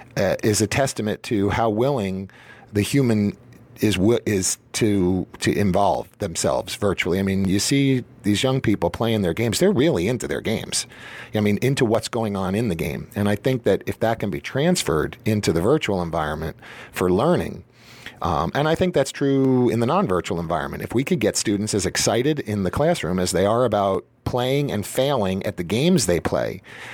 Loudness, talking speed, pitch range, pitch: -22 LUFS, 195 wpm, 95-130 Hz, 105 Hz